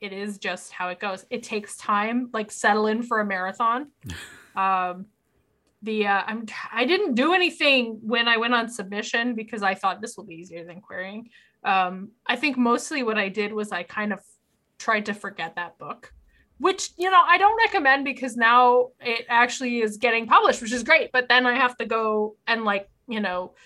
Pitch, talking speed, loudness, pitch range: 220 Hz, 205 wpm, -22 LUFS, 200-245 Hz